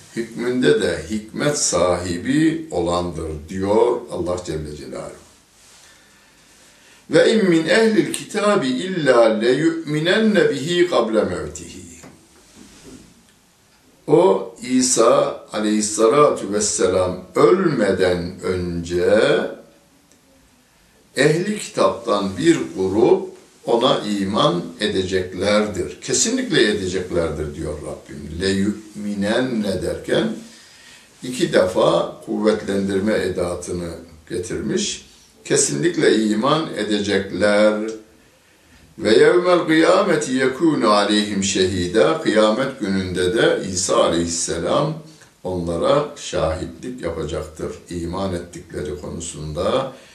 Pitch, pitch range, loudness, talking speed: 105 Hz, 90-145 Hz, -19 LUFS, 75 wpm